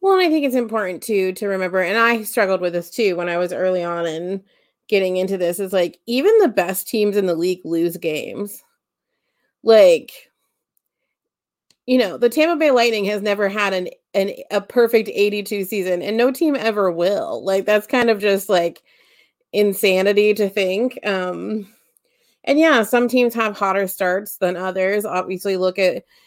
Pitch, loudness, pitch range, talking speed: 205 Hz, -18 LUFS, 185-240 Hz, 180 wpm